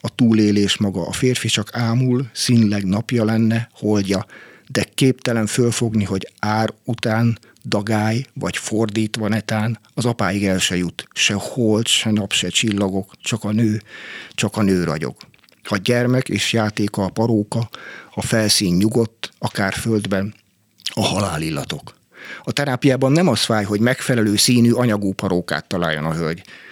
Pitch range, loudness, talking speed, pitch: 100-120 Hz, -19 LUFS, 150 wpm, 110 Hz